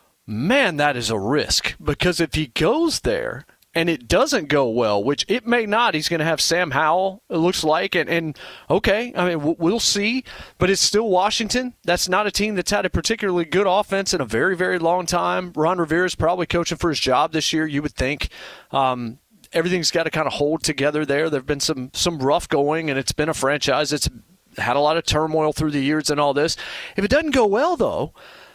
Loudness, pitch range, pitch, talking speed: -20 LUFS, 150-185 Hz, 165 Hz, 225 wpm